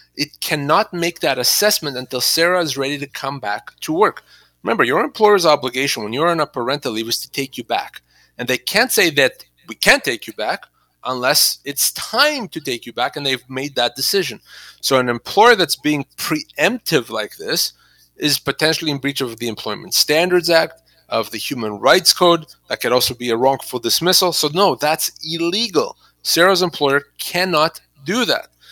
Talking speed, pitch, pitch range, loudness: 185 wpm, 150 Hz, 130-170 Hz, -17 LUFS